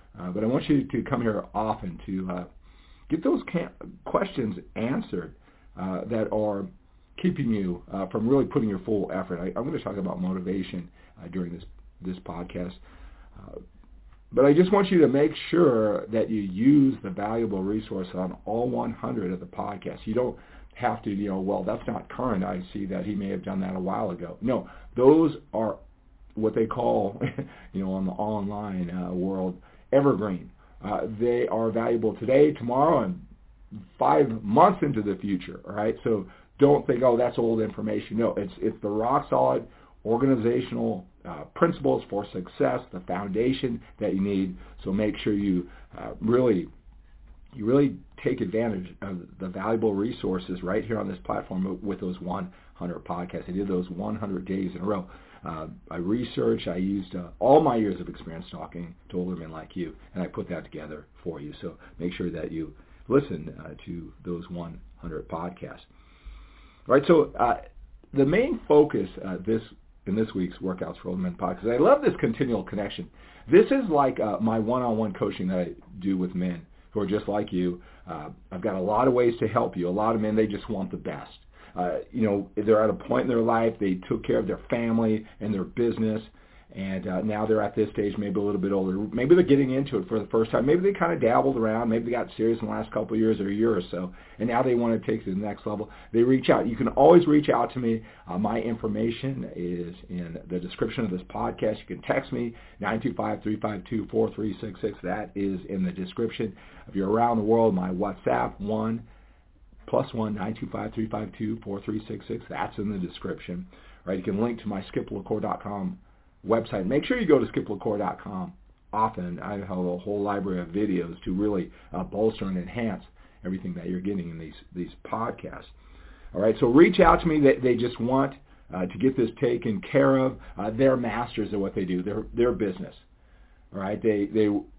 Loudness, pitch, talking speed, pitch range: -26 LUFS, 105 Hz, 205 wpm, 90-115 Hz